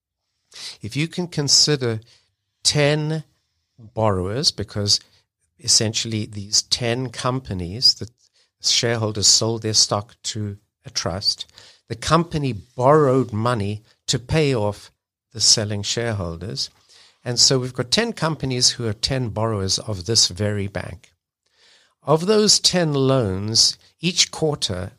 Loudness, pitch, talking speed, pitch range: -19 LUFS, 115 Hz, 120 wpm, 105-135 Hz